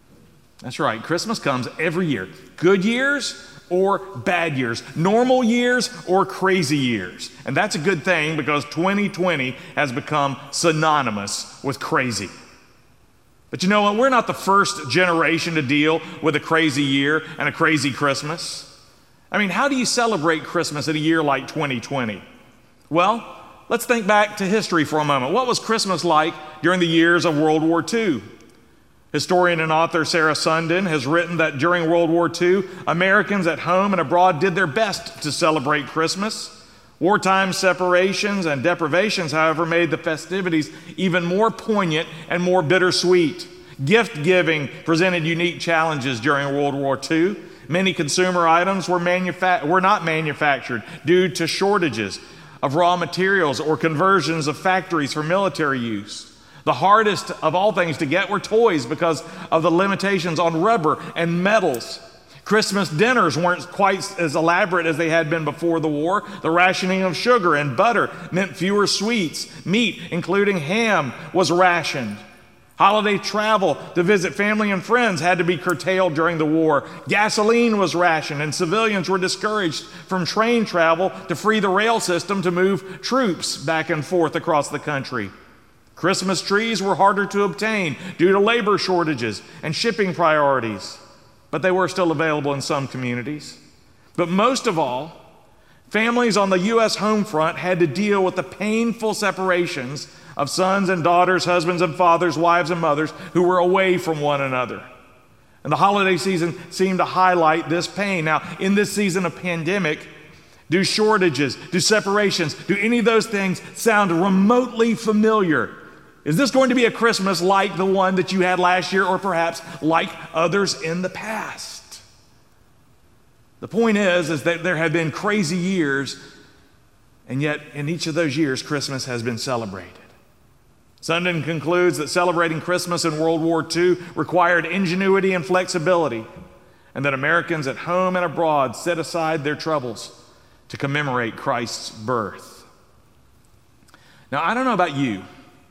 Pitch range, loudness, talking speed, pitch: 155-190 Hz, -20 LUFS, 160 wpm, 175 Hz